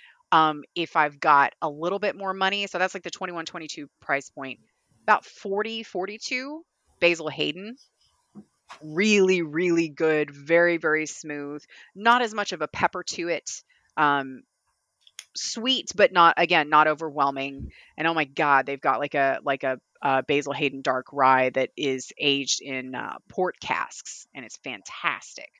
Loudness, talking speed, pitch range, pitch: -24 LUFS, 160 wpm, 140-185 Hz, 155 Hz